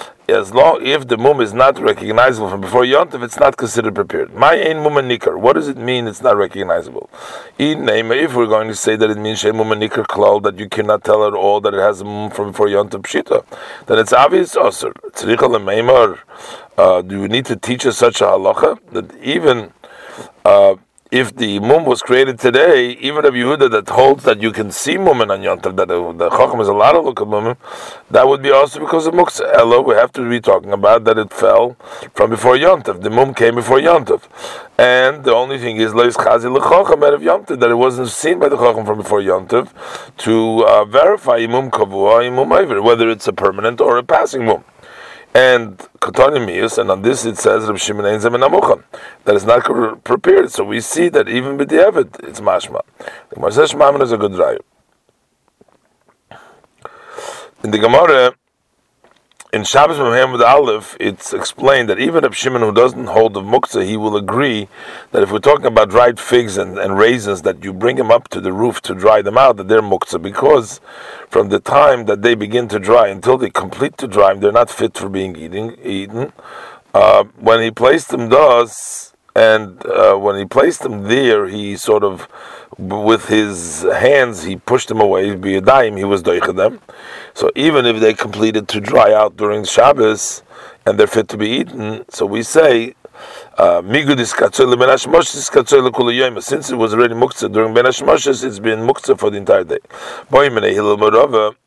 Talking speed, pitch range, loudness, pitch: 180 wpm, 105-140 Hz, -13 LUFS, 120 Hz